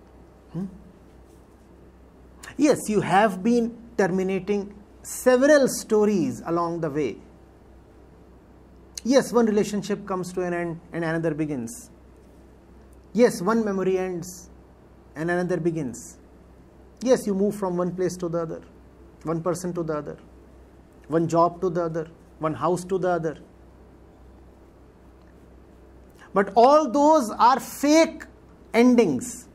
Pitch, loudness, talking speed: 170 Hz, -23 LUFS, 120 wpm